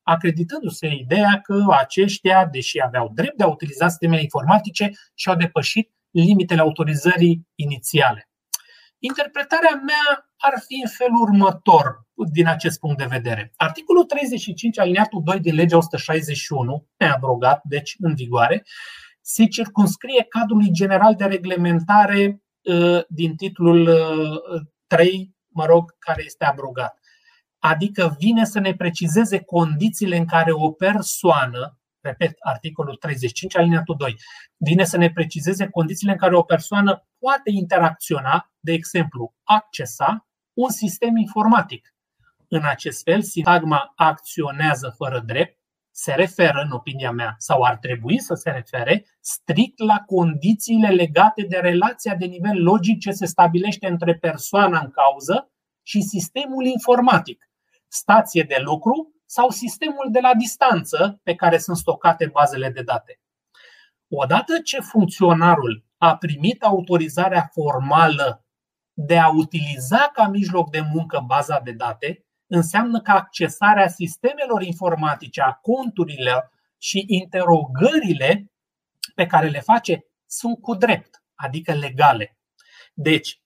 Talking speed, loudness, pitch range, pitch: 125 wpm, -19 LUFS, 160-210 Hz, 175 Hz